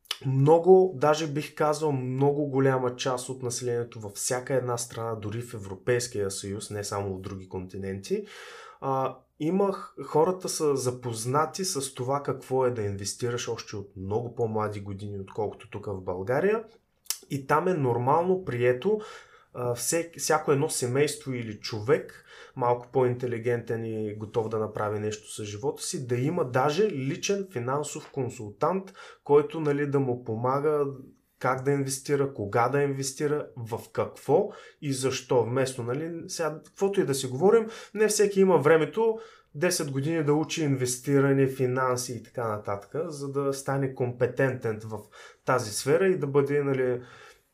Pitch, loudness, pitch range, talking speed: 135 Hz, -27 LUFS, 120-150 Hz, 145 wpm